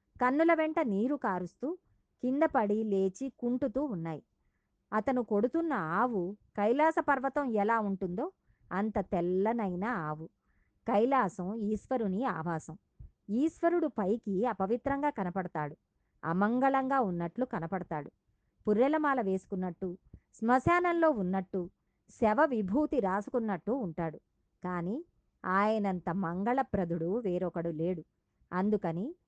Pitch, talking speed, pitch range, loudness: 210 Hz, 85 wpm, 185-260 Hz, -32 LUFS